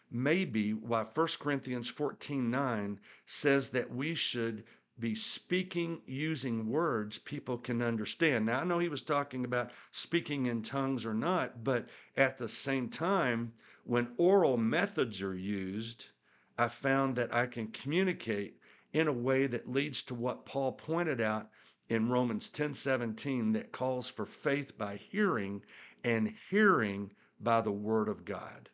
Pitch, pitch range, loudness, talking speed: 125 Hz, 115-145 Hz, -33 LUFS, 150 wpm